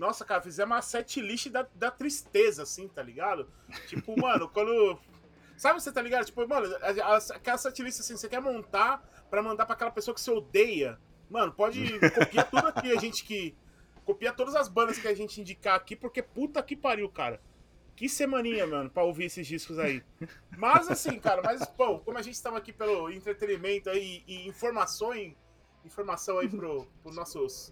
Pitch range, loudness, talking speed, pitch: 200-260 Hz, -30 LUFS, 185 wpm, 225 Hz